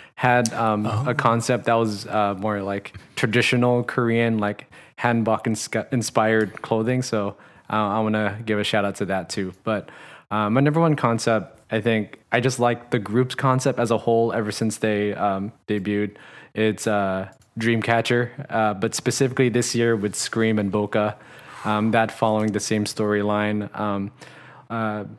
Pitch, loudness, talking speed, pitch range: 110 Hz, -22 LUFS, 170 wpm, 105-120 Hz